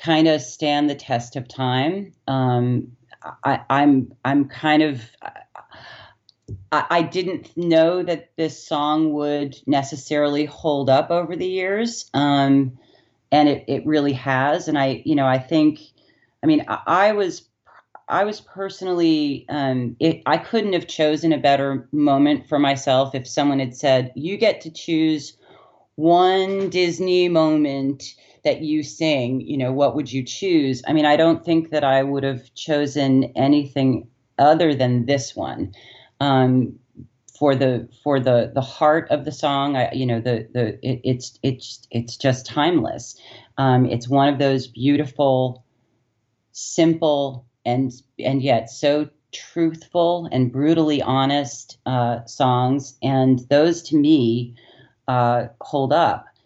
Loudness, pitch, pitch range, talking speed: -20 LUFS, 140 Hz, 130-155 Hz, 145 wpm